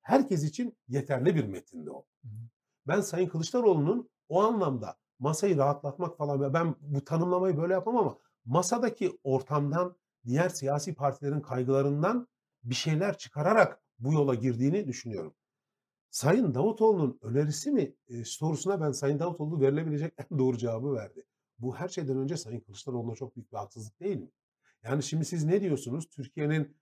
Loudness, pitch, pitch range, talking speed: -30 LUFS, 145 Hz, 130-175 Hz, 145 wpm